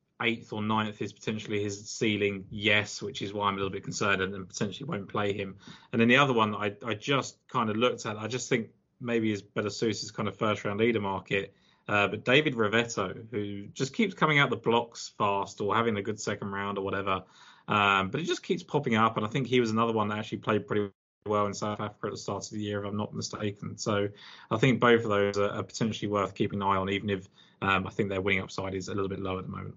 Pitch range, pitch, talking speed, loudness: 100-115 Hz, 105 Hz, 260 wpm, -29 LUFS